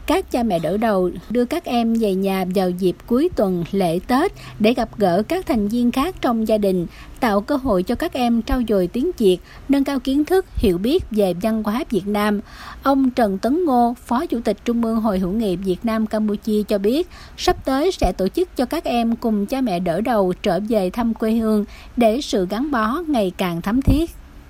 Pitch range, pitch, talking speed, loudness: 200-265 Hz, 225 Hz, 220 wpm, -20 LUFS